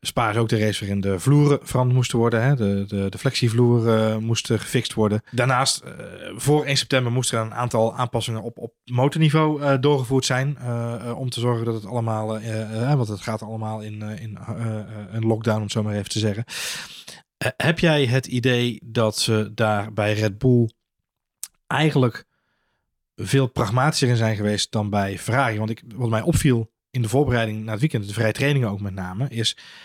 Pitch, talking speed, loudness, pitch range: 115 Hz, 205 wpm, -22 LUFS, 110-130 Hz